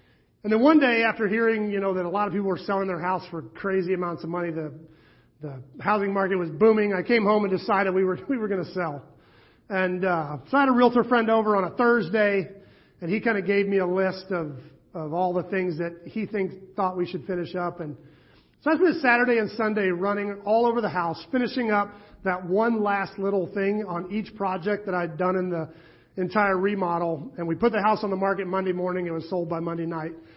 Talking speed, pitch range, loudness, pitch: 235 wpm, 175-210 Hz, -25 LUFS, 190 Hz